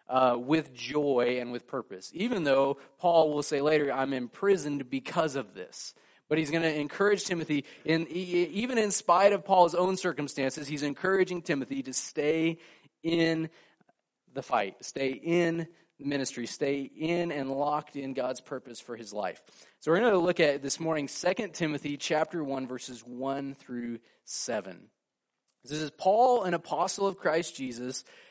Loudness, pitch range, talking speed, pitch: -29 LUFS, 135-170 Hz, 165 wpm, 150 Hz